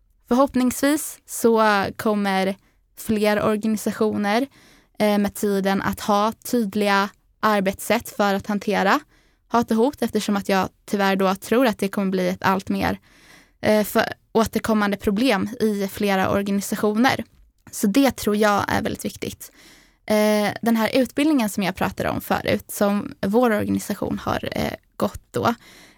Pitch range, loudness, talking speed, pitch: 200-225 Hz, -22 LUFS, 130 wpm, 210 Hz